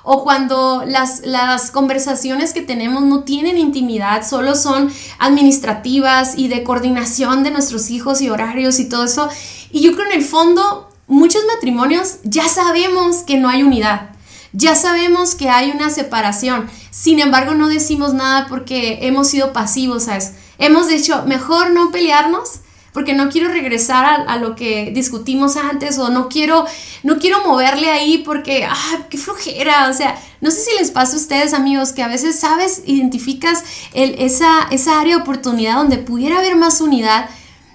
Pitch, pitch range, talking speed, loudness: 275 Hz, 255-315 Hz, 170 wpm, -13 LUFS